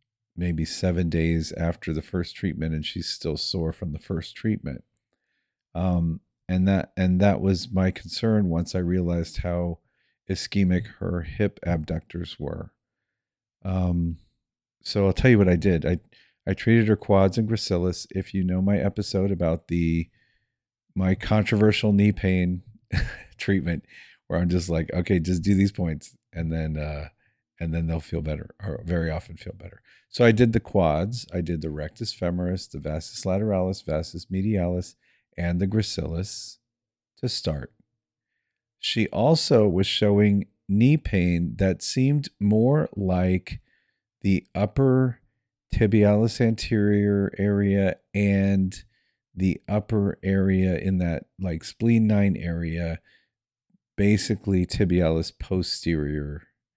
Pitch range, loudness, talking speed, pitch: 85-105 Hz, -24 LUFS, 135 wpm, 95 Hz